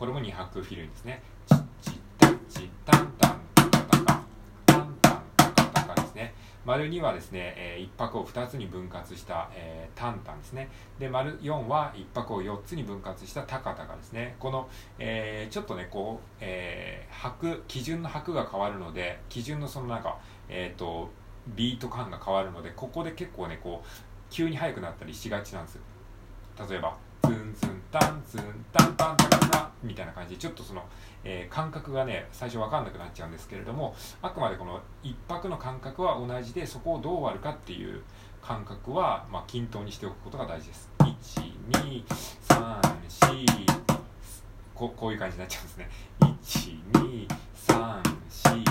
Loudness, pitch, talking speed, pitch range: -28 LUFS, 105 Hz, 290 characters per minute, 95-125 Hz